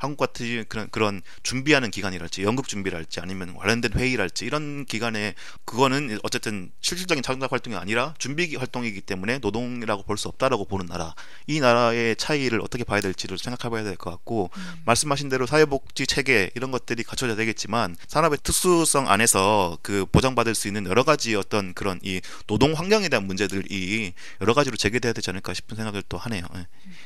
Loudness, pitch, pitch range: -24 LUFS, 115 Hz, 100-130 Hz